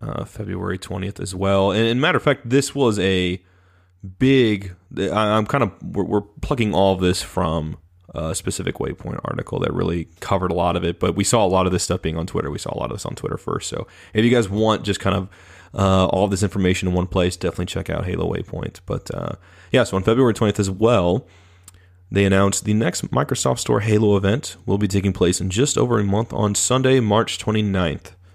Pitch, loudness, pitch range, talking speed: 95 Hz, -20 LUFS, 90-110 Hz, 220 wpm